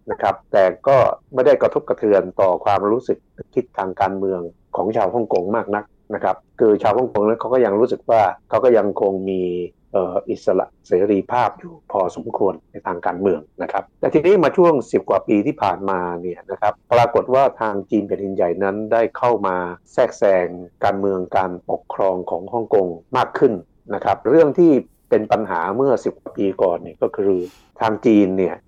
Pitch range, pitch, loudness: 90-105 Hz, 95 Hz, -19 LUFS